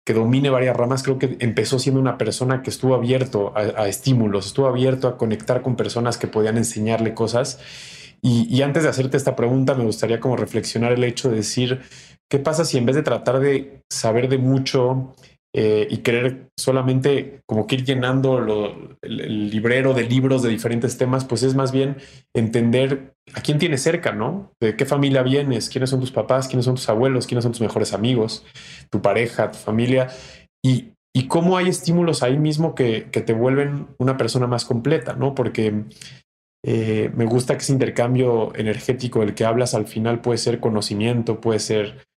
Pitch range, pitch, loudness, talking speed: 115-135 Hz, 125 Hz, -20 LUFS, 190 wpm